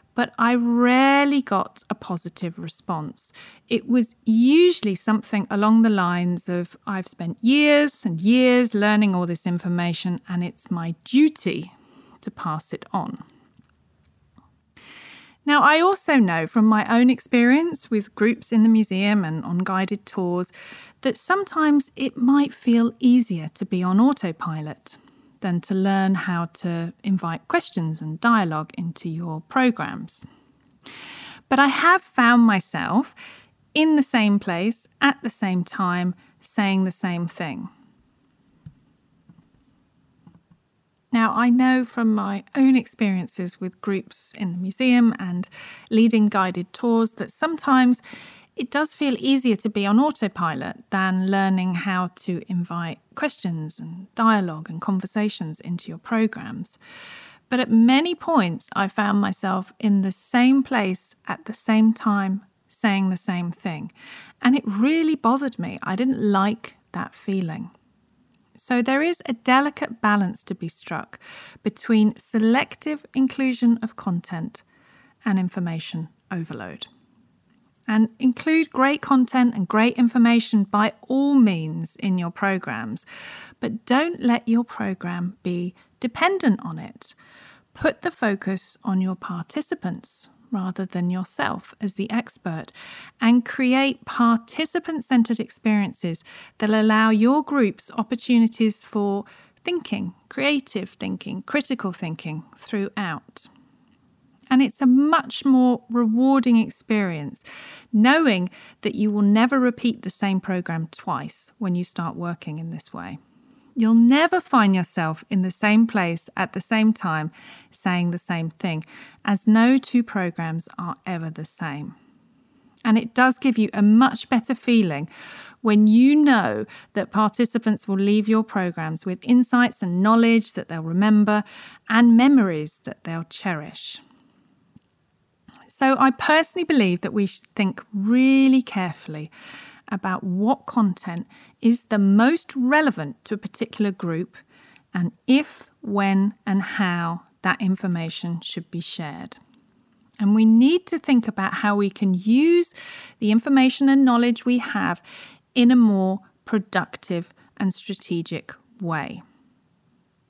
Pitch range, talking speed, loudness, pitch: 185-250 Hz, 135 wpm, -21 LUFS, 220 Hz